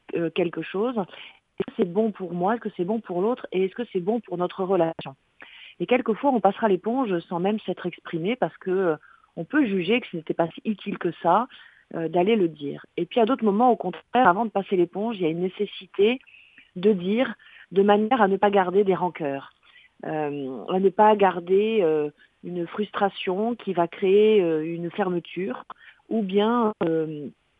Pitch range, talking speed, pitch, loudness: 175-215 Hz, 185 wpm, 195 Hz, -24 LUFS